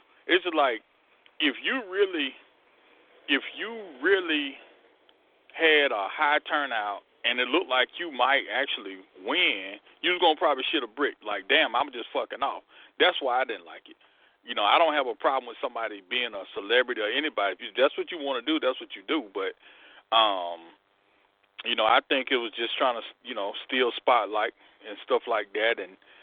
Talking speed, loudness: 190 wpm, -26 LUFS